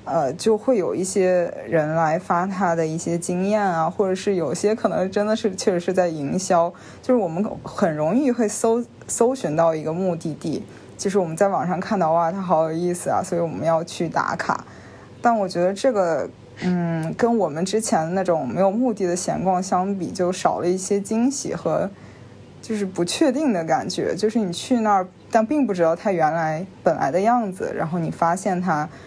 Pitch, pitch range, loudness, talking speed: 185 Hz, 170-210 Hz, -22 LUFS, 285 characters per minute